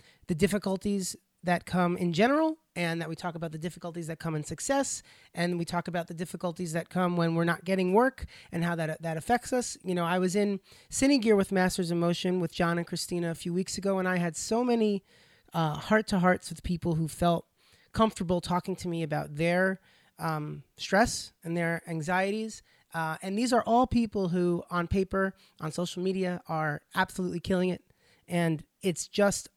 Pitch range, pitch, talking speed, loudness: 170-195 Hz, 180 Hz, 200 wpm, -30 LUFS